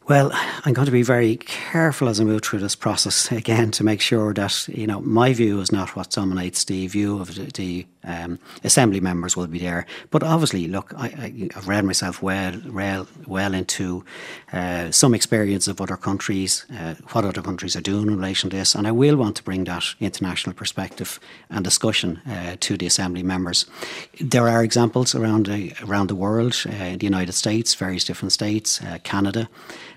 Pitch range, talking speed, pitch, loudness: 95-115 Hz, 195 wpm, 100 Hz, -21 LUFS